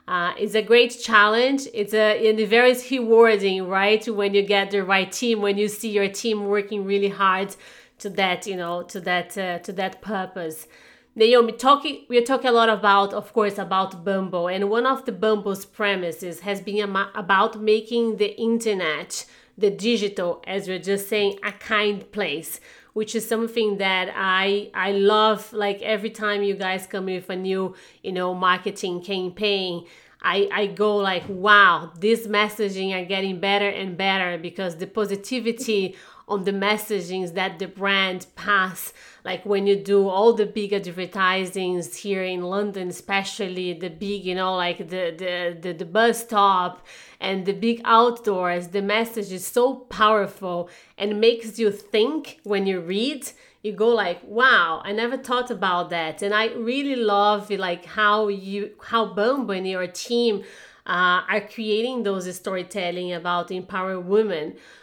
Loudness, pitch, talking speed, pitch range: -22 LUFS, 200 Hz, 170 wpm, 185-215 Hz